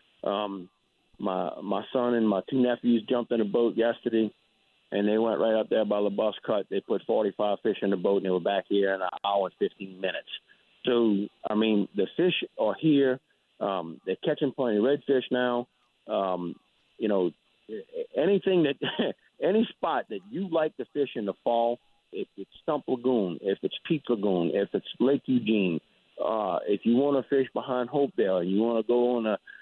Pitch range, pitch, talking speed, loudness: 105-135 Hz, 120 Hz, 195 wpm, -28 LUFS